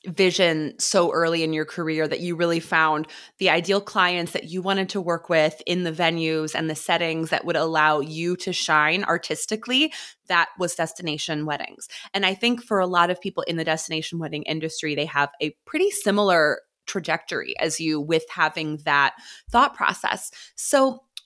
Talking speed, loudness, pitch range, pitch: 180 wpm, -23 LUFS, 155-190 Hz, 165 Hz